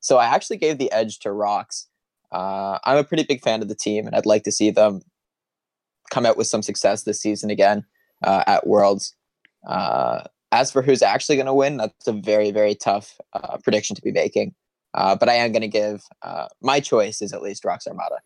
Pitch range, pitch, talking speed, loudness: 105-120 Hz, 105 Hz, 220 wpm, -21 LUFS